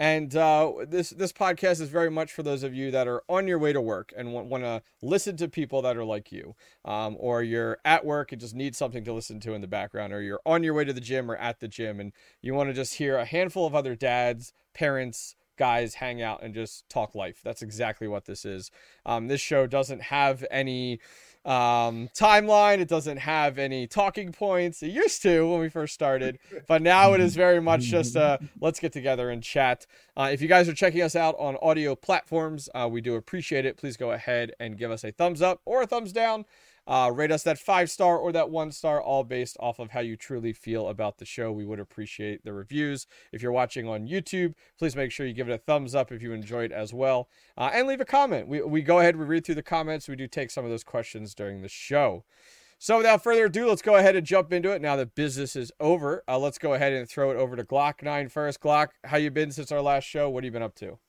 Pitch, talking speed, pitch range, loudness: 140 Hz, 250 wpm, 120-165 Hz, -26 LUFS